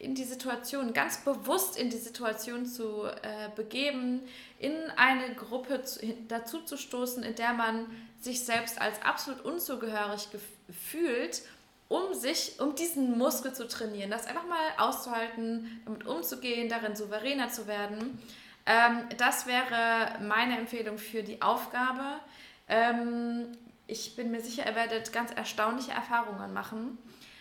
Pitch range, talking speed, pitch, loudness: 225-255 Hz, 130 wpm, 235 Hz, -32 LUFS